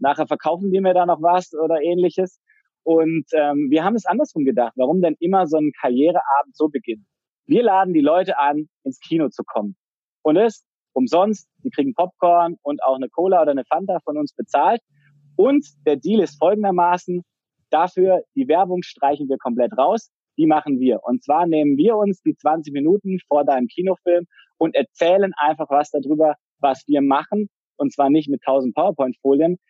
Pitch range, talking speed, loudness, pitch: 145-185 Hz, 180 wpm, -19 LUFS, 160 Hz